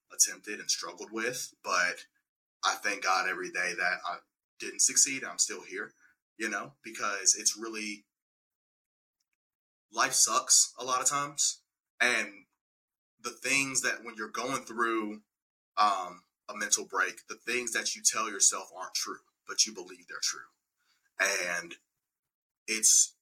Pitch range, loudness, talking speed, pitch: 110-130 Hz, -28 LUFS, 140 wpm, 115 Hz